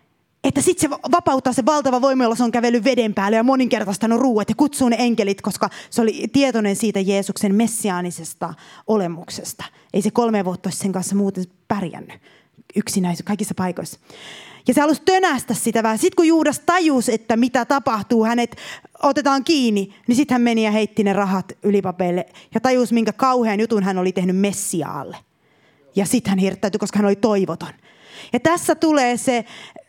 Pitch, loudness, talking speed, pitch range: 225 Hz, -19 LUFS, 170 wpm, 200-260 Hz